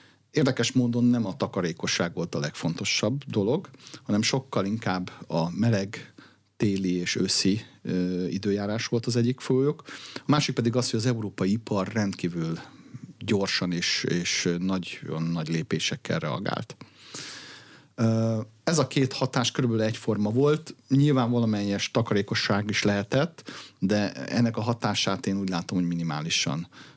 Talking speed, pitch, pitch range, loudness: 140 wpm, 110 Hz, 95-125 Hz, -26 LUFS